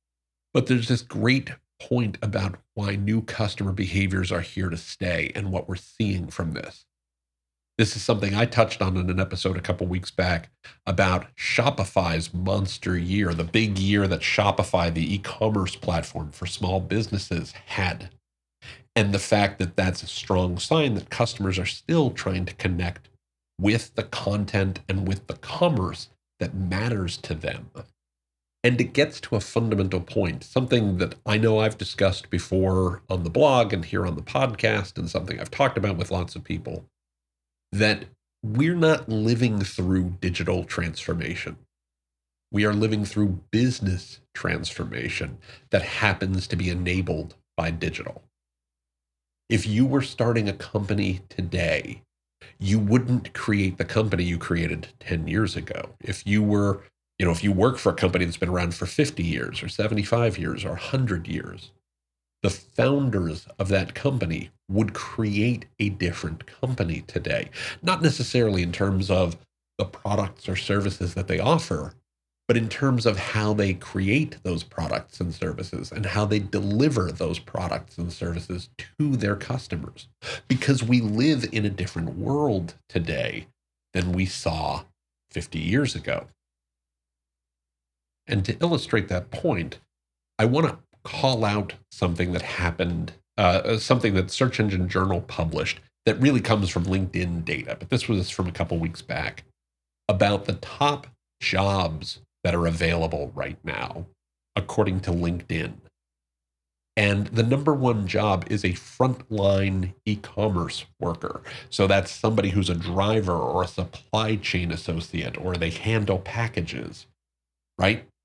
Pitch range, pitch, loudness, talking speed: 85-110 Hz, 95 Hz, -25 LUFS, 150 wpm